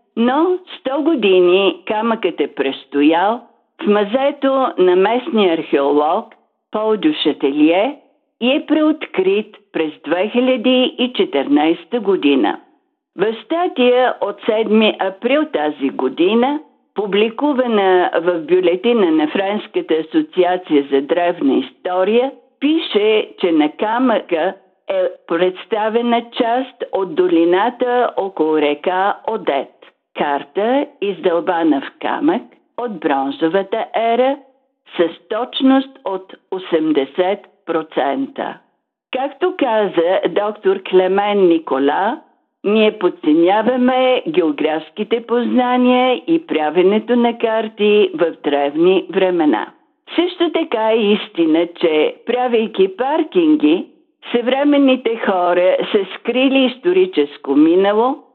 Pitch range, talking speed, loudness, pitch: 180-270 Hz, 90 wpm, -16 LUFS, 225 Hz